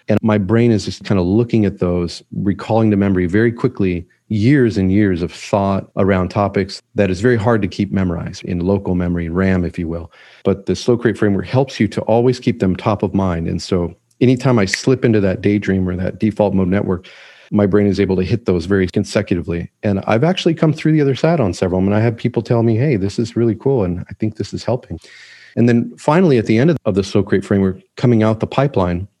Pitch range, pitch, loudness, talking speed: 95-120 Hz, 105 Hz, -16 LUFS, 240 wpm